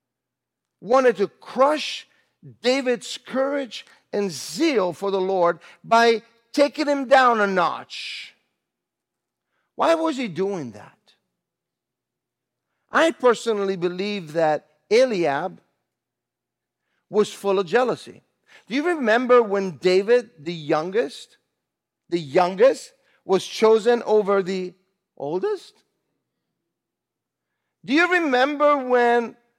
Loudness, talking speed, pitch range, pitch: -21 LUFS, 95 wpm, 190-270 Hz, 230 Hz